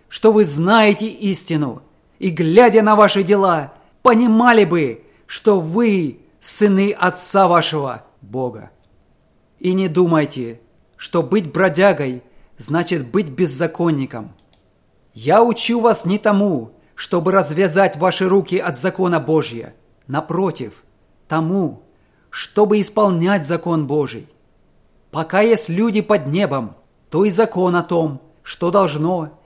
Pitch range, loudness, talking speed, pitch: 150-200 Hz, -16 LUFS, 115 wpm, 180 Hz